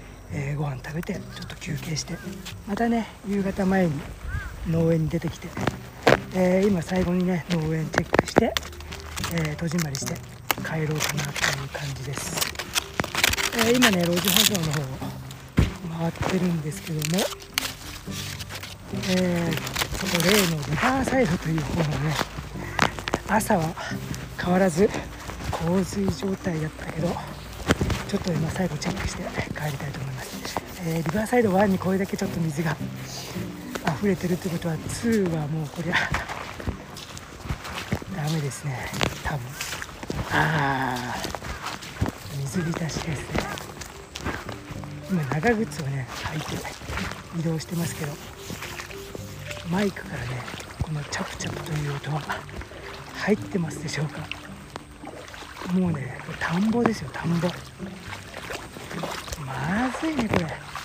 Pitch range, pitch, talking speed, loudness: 140-185 Hz, 165 Hz, 255 characters per minute, -26 LUFS